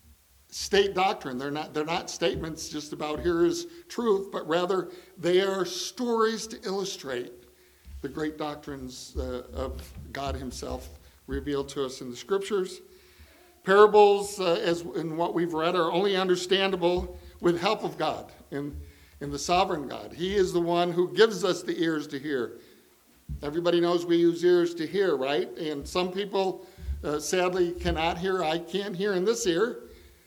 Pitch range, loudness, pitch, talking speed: 150-195 Hz, -27 LUFS, 175 Hz, 165 wpm